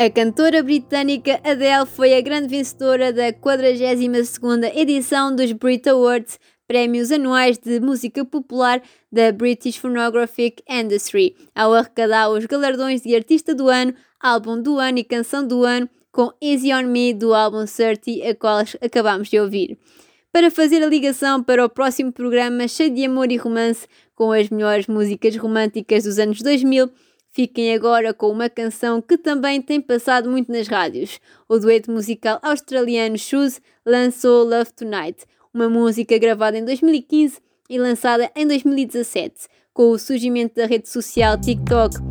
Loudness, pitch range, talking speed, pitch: -18 LUFS, 230-270 Hz, 150 wpm, 245 Hz